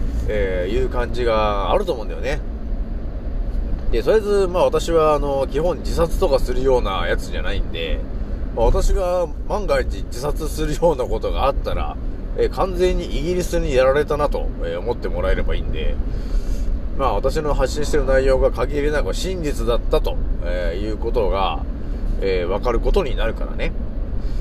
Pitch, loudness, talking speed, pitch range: 145 Hz, -22 LUFS, 335 characters per minute, 125-180 Hz